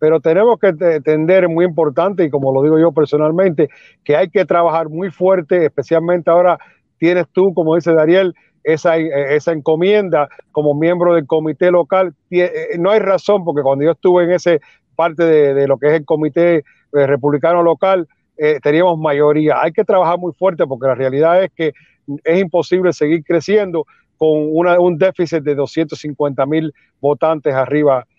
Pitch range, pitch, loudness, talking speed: 150-180 Hz, 165 Hz, -14 LUFS, 165 wpm